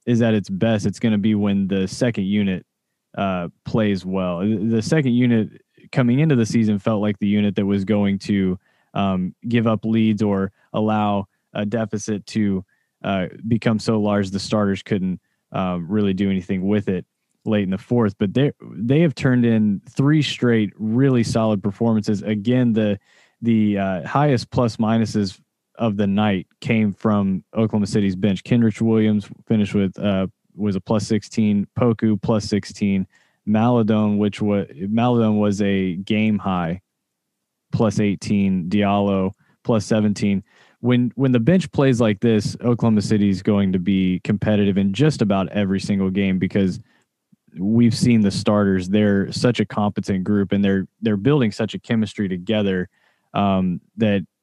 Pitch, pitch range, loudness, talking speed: 105 Hz, 100-115 Hz, -20 LUFS, 160 wpm